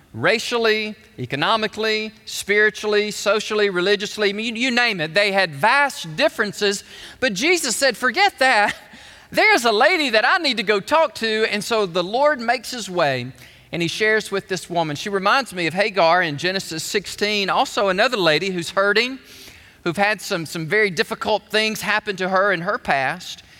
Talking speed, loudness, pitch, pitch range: 170 wpm, -19 LUFS, 210 Hz, 195-225 Hz